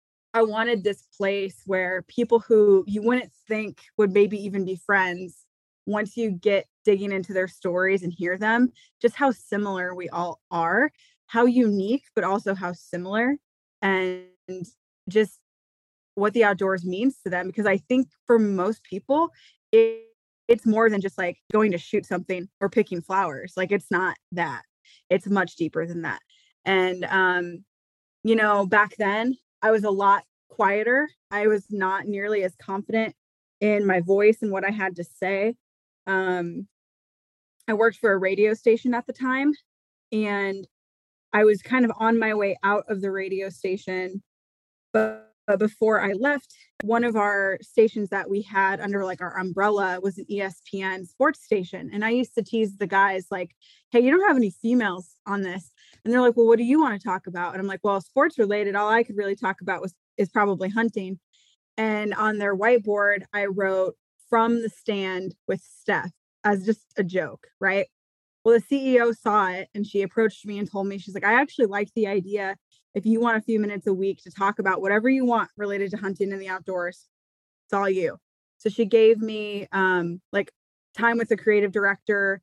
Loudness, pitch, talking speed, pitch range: -24 LUFS, 200 Hz, 185 wpm, 190-225 Hz